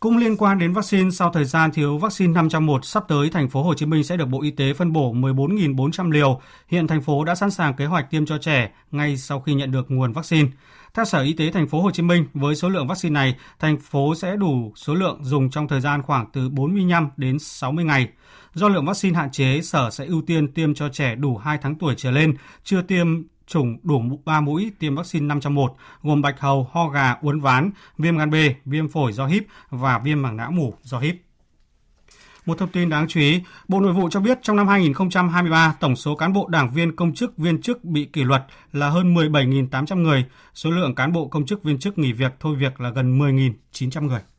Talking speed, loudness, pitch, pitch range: 230 wpm, -21 LUFS, 150 Hz, 140-170 Hz